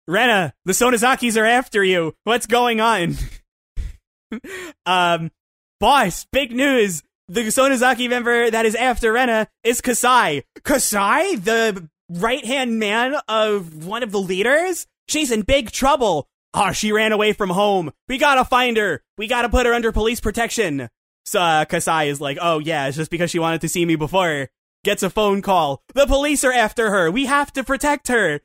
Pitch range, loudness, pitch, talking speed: 175-250 Hz, -18 LUFS, 220 Hz, 180 wpm